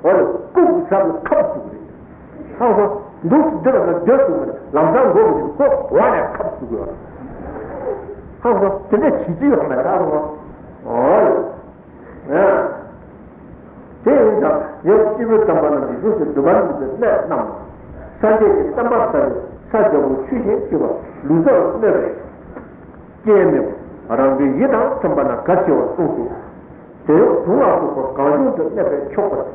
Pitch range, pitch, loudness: 185-305 Hz, 220 Hz, -16 LUFS